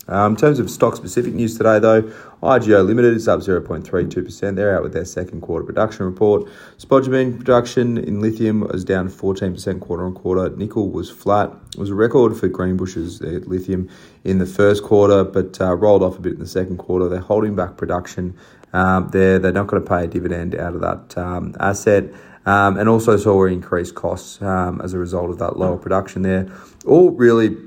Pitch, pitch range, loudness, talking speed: 95 Hz, 90-110 Hz, -18 LUFS, 195 wpm